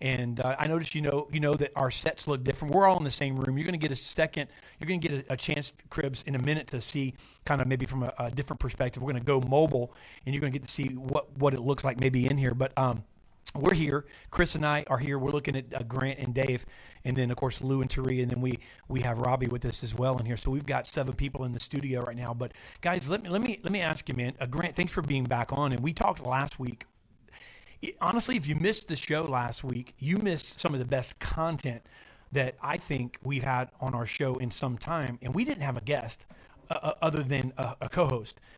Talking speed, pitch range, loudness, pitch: 270 wpm, 125-150 Hz, -30 LUFS, 135 Hz